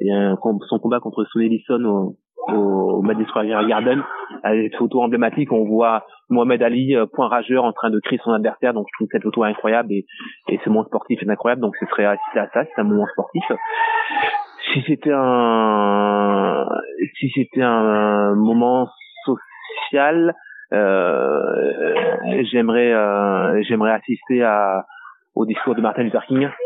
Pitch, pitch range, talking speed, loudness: 120 Hz, 110-145 Hz, 155 wpm, -19 LUFS